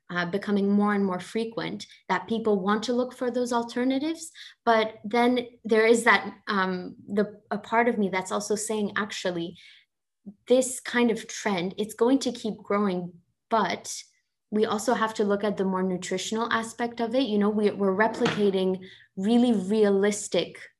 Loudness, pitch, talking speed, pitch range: -26 LUFS, 215 Hz, 165 wpm, 200-235 Hz